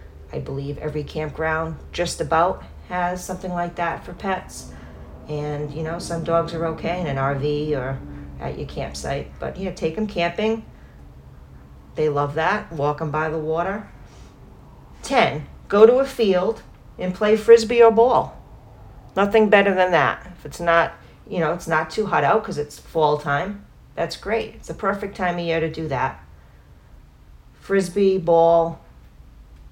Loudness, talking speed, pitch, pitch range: -21 LUFS, 160 wpm, 160 Hz, 135-180 Hz